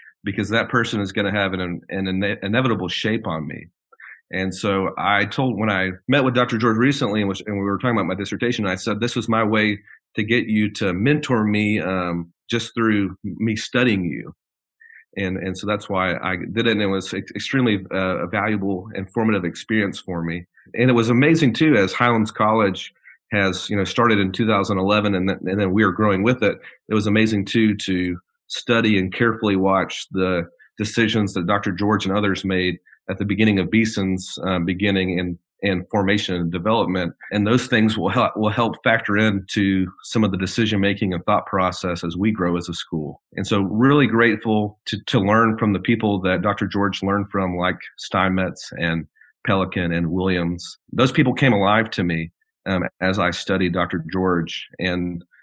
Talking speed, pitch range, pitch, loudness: 195 wpm, 95-110 Hz, 100 Hz, -20 LUFS